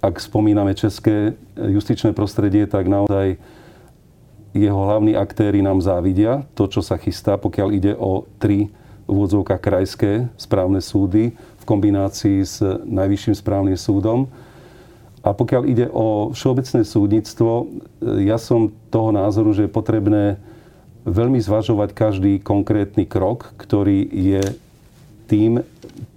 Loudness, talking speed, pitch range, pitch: -18 LUFS, 115 wpm, 100-110 Hz, 105 Hz